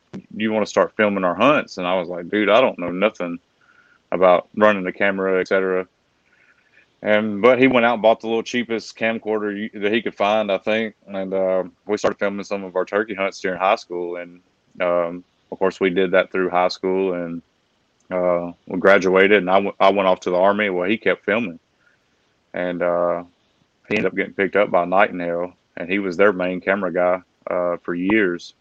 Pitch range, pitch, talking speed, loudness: 90-105 Hz, 95 Hz, 210 wpm, -20 LUFS